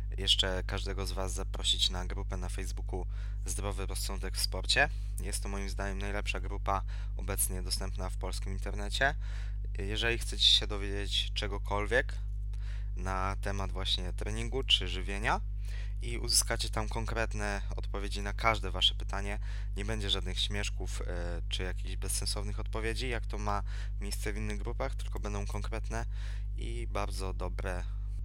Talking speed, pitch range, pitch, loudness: 140 wpm, 95-105 Hz, 100 Hz, -33 LUFS